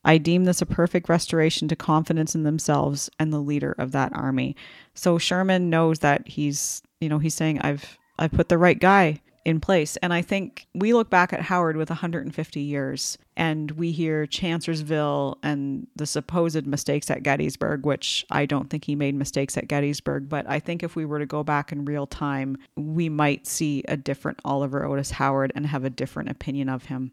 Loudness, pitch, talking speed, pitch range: -24 LUFS, 150 Hz, 200 wpm, 140-165 Hz